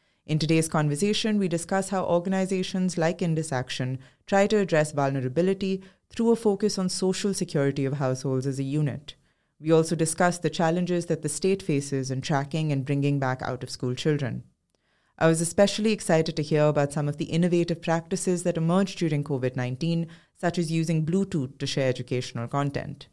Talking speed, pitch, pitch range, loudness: 170 wpm, 160 Hz, 140-180 Hz, -26 LUFS